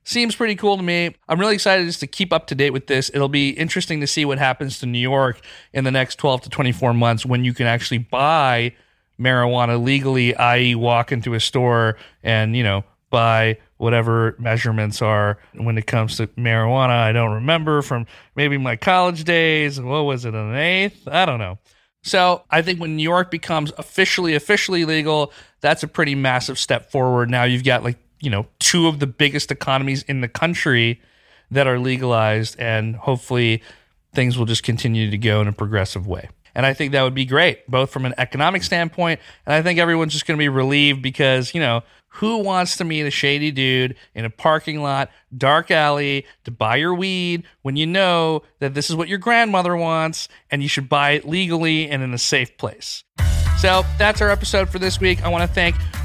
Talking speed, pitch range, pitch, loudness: 205 wpm, 120-155 Hz, 135 Hz, -19 LUFS